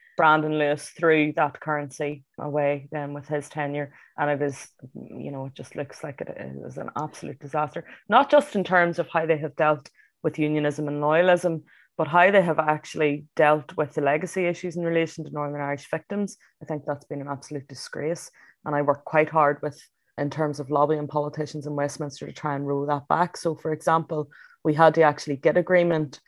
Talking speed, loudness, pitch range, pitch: 200 wpm, -24 LUFS, 145-160 Hz, 150 Hz